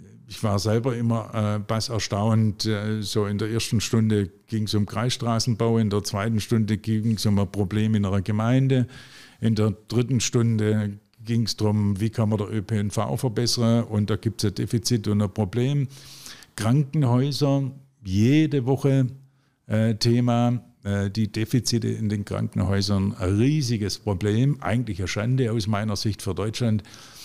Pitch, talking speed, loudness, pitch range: 110 Hz, 160 wpm, -24 LUFS, 105-120 Hz